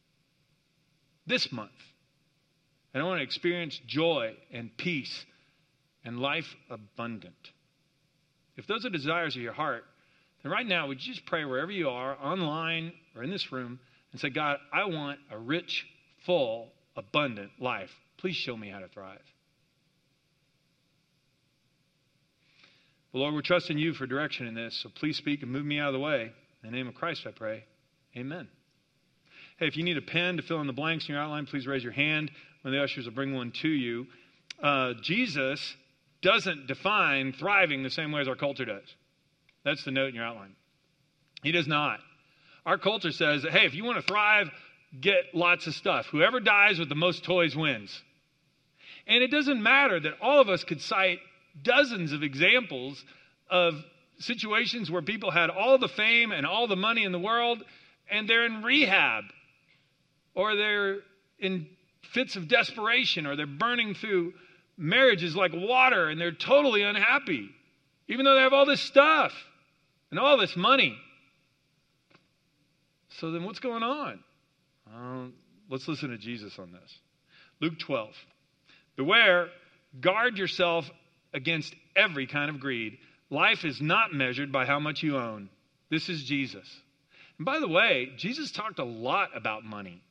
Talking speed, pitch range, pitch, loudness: 165 wpm, 140-180 Hz, 155 Hz, -27 LUFS